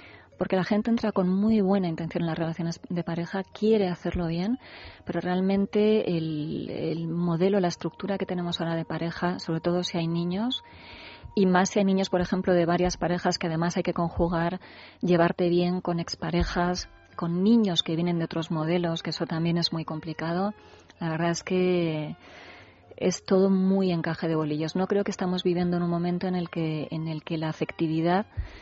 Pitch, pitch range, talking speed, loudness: 175 Hz, 165-185 Hz, 190 wpm, -27 LUFS